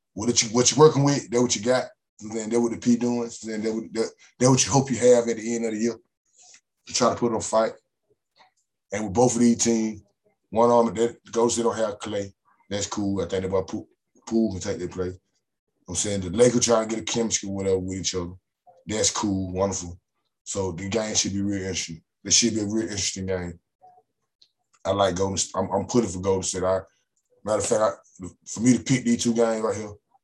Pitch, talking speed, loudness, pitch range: 110 Hz, 245 wpm, -24 LUFS, 95-120 Hz